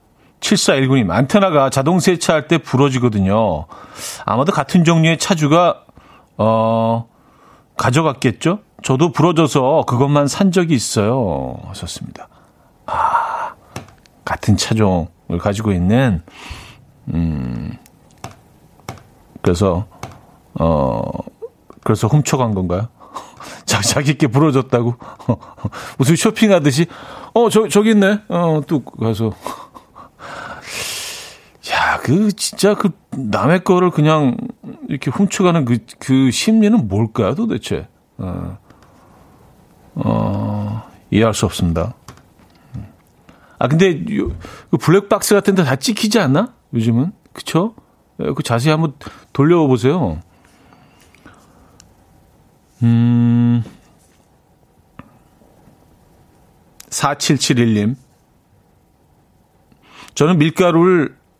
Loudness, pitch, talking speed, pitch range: -16 LUFS, 135 Hz, 180 characters per minute, 110-175 Hz